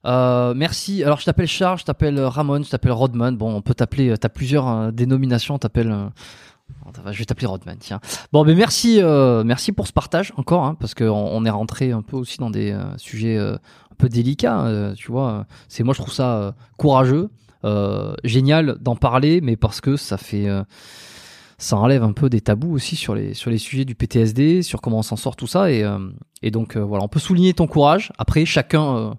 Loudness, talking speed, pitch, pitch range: -19 LUFS, 220 wpm, 125 Hz, 110-145 Hz